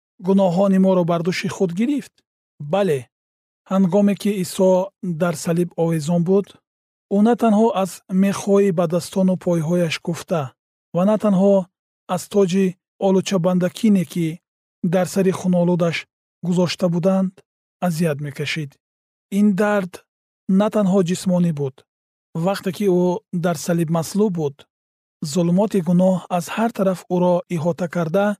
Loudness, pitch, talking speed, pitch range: -20 LUFS, 185 Hz, 125 wpm, 170-195 Hz